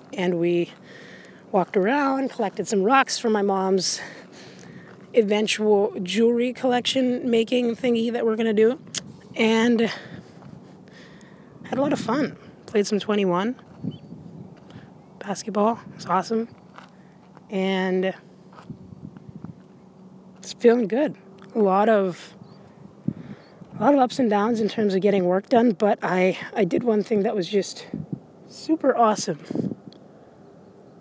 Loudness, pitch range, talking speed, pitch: -22 LUFS, 190-230 Hz, 120 wpm, 205 Hz